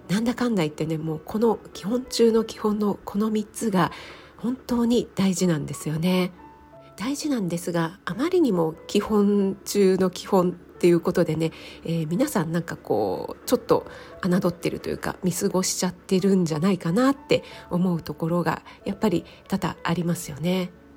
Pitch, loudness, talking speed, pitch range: 185 Hz, -24 LUFS, 355 characters per minute, 170-220 Hz